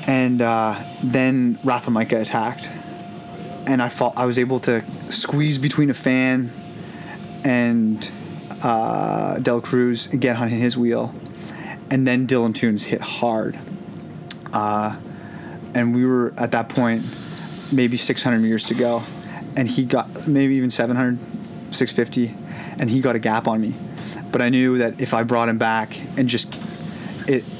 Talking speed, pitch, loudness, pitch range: 150 wpm, 125 Hz, -21 LUFS, 120-140 Hz